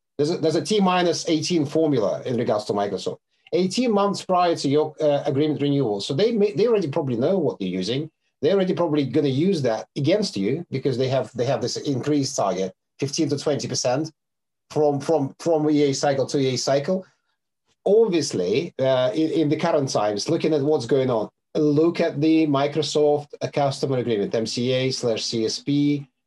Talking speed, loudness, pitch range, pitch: 180 wpm, -22 LUFS, 135-160 Hz, 150 Hz